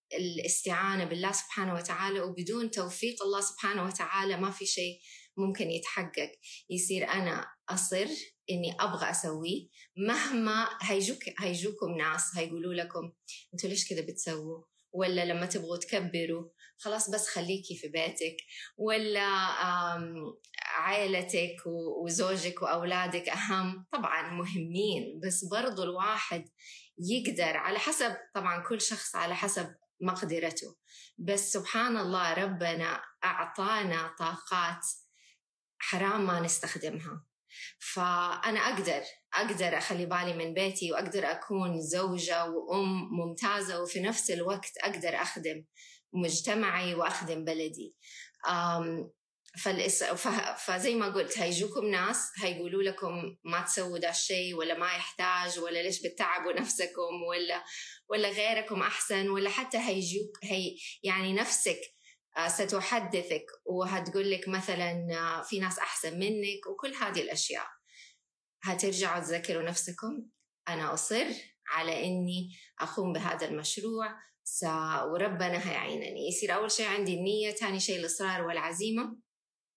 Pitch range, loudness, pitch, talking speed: 170-200 Hz, -32 LUFS, 185 Hz, 110 wpm